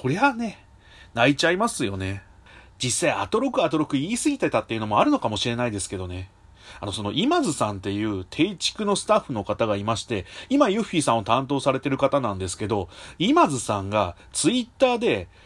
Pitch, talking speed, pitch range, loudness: 115 Hz, 425 characters per minute, 100-160 Hz, -24 LUFS